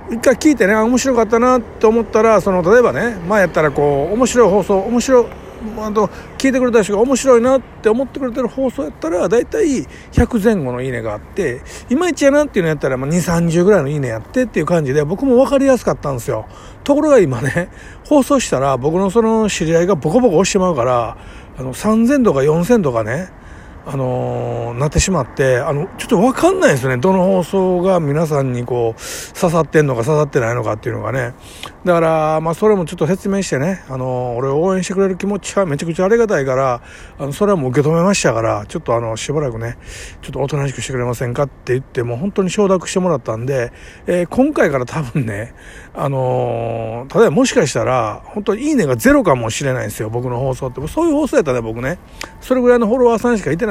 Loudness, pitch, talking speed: -16 LUFS, 175 Hz, 455 characters per minute